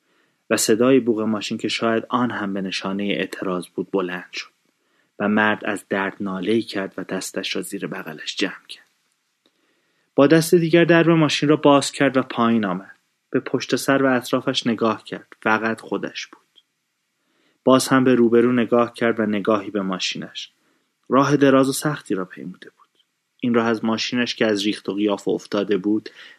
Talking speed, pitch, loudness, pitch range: 175 wpm, 115 Hz, -20 LUFS, 105-130 Hz